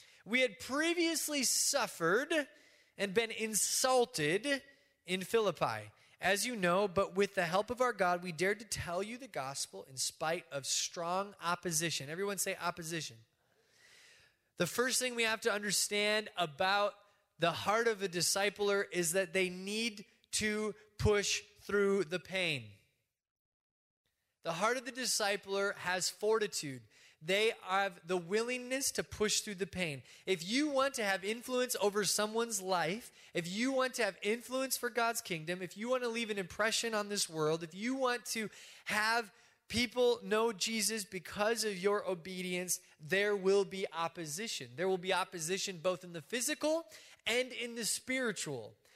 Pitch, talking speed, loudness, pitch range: 205 Hz, 155 wpm, -34 LUFS, 180-235 Hz